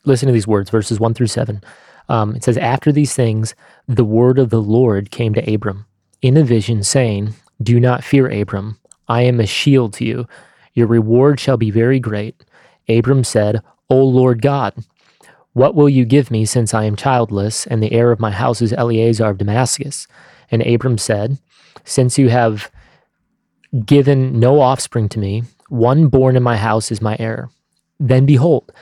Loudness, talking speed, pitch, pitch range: -15 LUFS, 180 wpm, 120 Hz, 110-130 Hz